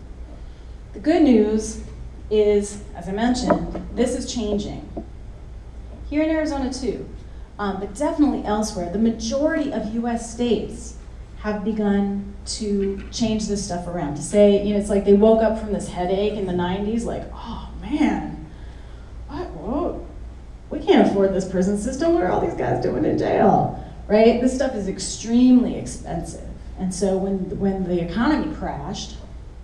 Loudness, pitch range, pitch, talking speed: -21 LUFS, 195-240 Hz, 210 Hz, 155 wpm